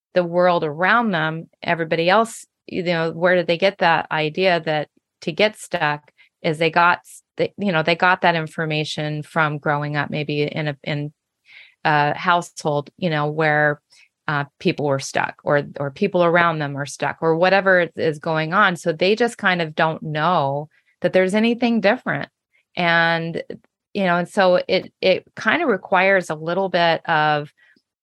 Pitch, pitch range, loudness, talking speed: 170 Hz, 150-180 Hz, -20 LUFS, 175 wpm